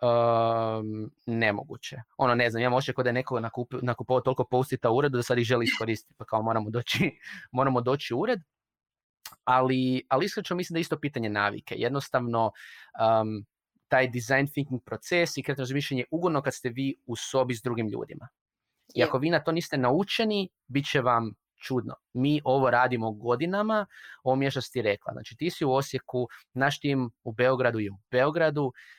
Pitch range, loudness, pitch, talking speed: 120-140 Hz, -28 LUFS, 130 Hz, 180 wpm